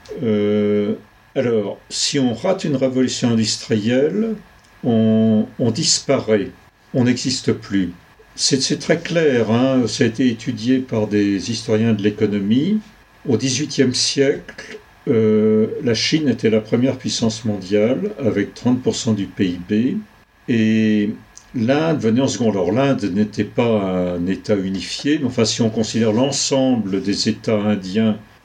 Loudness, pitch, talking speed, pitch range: -18 LUFS, 110 Hz, 135 wpm, 105-130 Hz